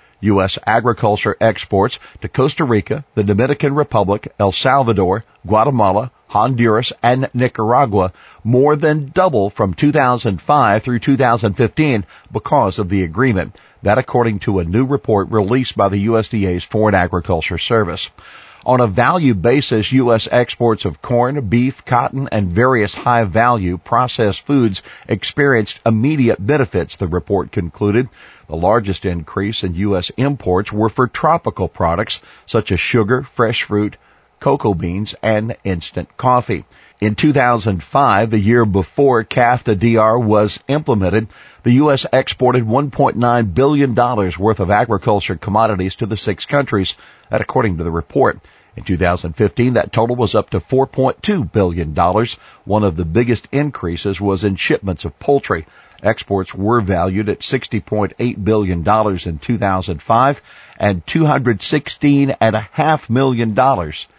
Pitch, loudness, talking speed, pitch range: 110 Hz, -16 LUFS, 130 wpm, 100-125 Hz